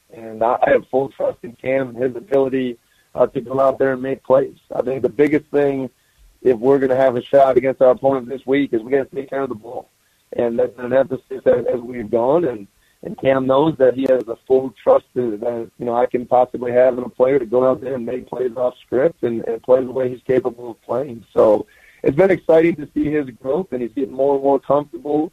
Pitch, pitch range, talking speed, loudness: 130 Hz, 125-140 Hz, 245 wpm, -18 LUFS